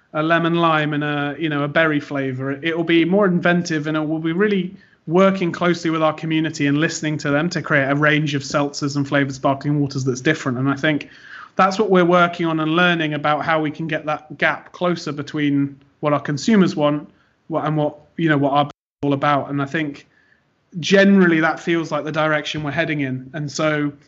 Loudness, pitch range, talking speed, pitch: -19 LUFS, 145-165 Hz, 220 wpm, 155 Hz